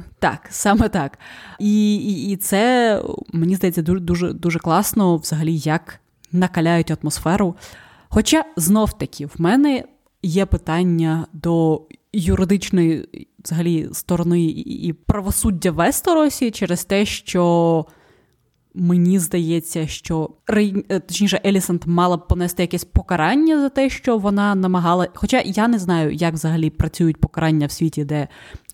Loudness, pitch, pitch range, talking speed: -19 LUFS, 175 Hz, 165-205 Hz, 125 wpm